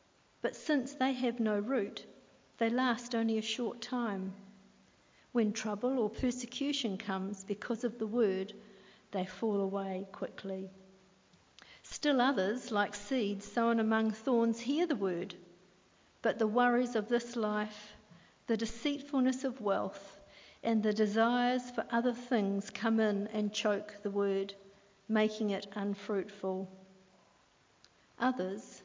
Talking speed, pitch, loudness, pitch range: 125 wpm, 215 Hz, -34 LUFS, 195-240 Hz